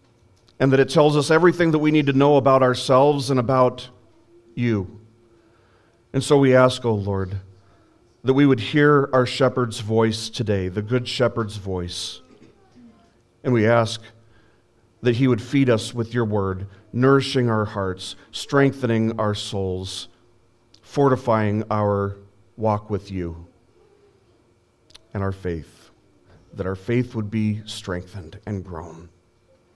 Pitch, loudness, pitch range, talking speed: 115 Hz, -21 LUFS, 100-125 Hz, 135 wpm